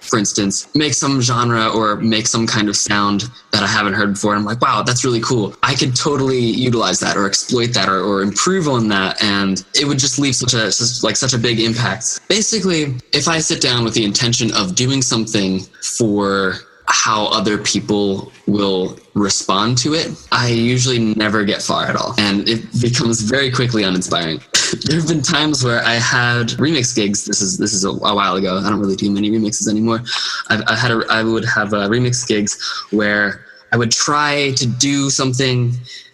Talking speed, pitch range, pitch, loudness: 200 wpm, 105-125 Hz, 115 Hz, -15 LUFS